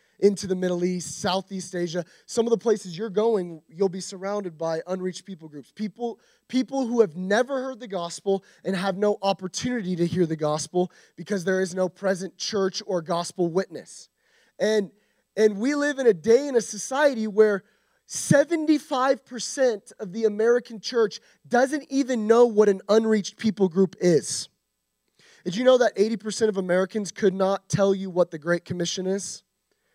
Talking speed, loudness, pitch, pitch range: 170 wpm, -24 LUFS, 200 Hz, 185-230 Hz